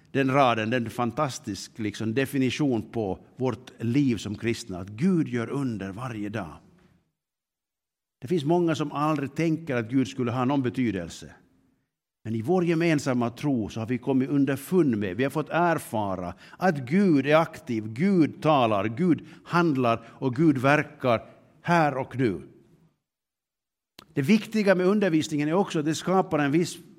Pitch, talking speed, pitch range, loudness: 135 Hz, 155 wpm, 115-160 Hz, -26 LUFS